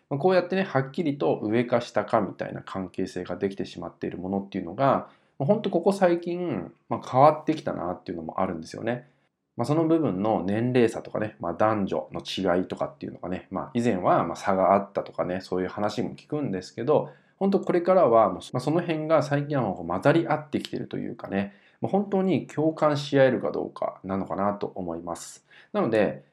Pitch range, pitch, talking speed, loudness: 95-155 Hz, 120 Hz, 385 characters per minute, -26 LUFS